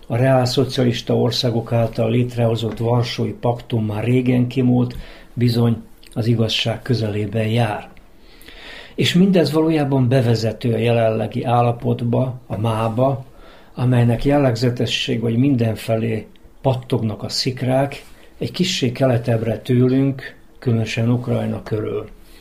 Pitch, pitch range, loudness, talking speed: 120 Hz, 115-130 Hz, -19 LUFS, 105 wpm